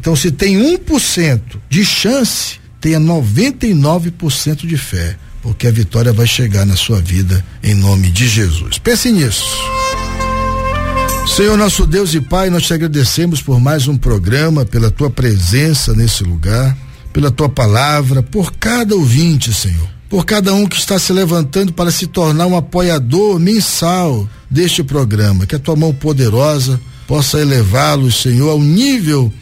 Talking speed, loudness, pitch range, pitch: 155 wpm, -12 LUFS, 110-170 Hz, 140 Hz